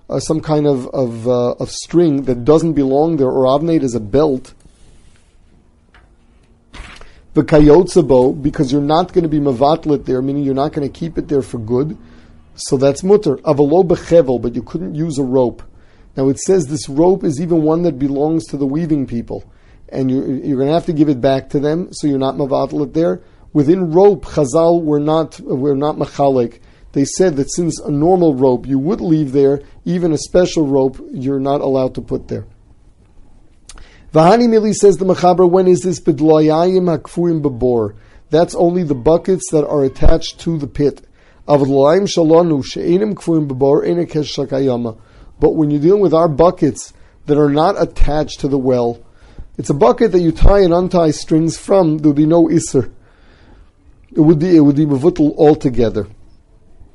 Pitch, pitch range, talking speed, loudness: 145 Hz, 130-165 Hz, 170 wpm, -14 LUFS